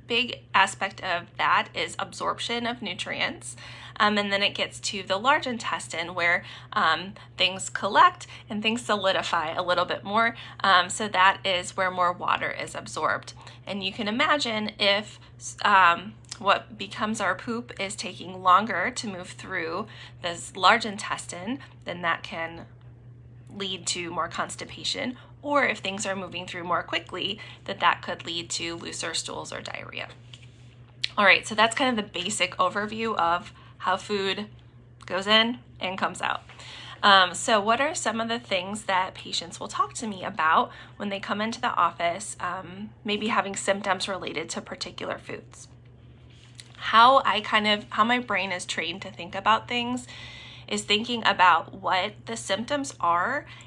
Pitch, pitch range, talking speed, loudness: 195 Hz, 170-215 Hz, 165 wpm, -25 LUFS